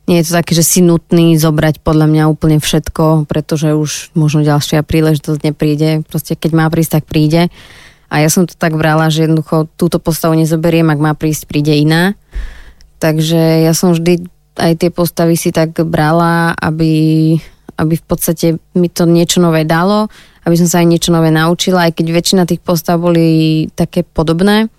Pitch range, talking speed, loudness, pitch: 155-170 Hz, 180 wpm, -11 LUFS, 165 Hz